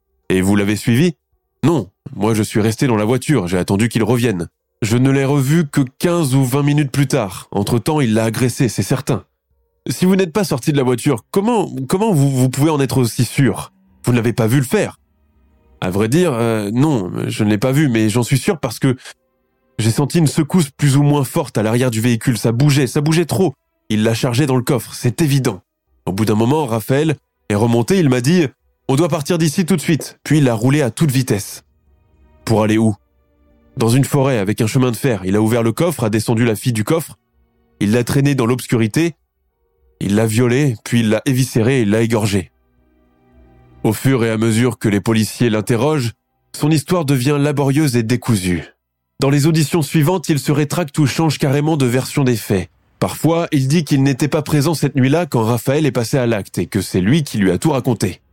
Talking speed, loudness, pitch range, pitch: 220 wpm, -16 LUFS, 110-145 Hz, 125 Hz